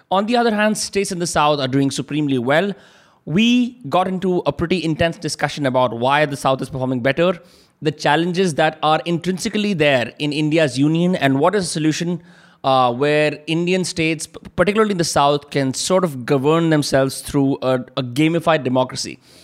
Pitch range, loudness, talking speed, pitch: 140-180 Hz, -18 LUFS, 180 wpm, 155 Hz